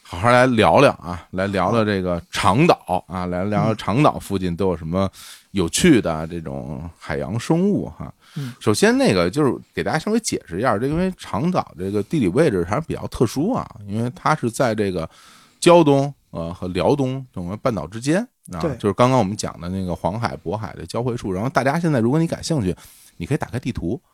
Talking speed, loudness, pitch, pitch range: 315 characters per minute, -20 LUFS, 110 Hz, 90-140 Hz